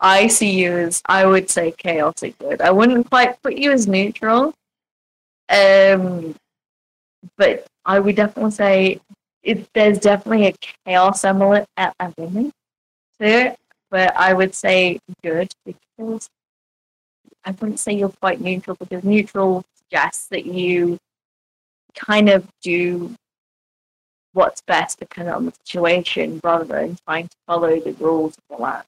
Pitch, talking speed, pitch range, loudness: 190 Hz, 140 wpm, 175-210 Hz, -17 LUFS